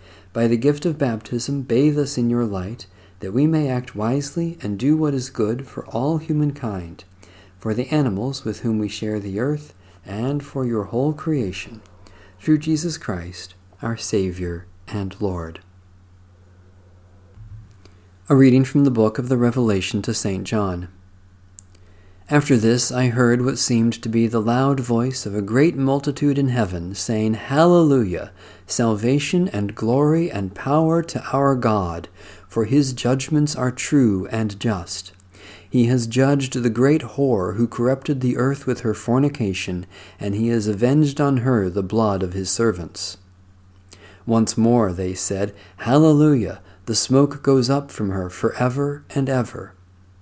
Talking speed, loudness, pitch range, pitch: 155 wpm, -20 LUFS, 95-135 Hz, 115 Hz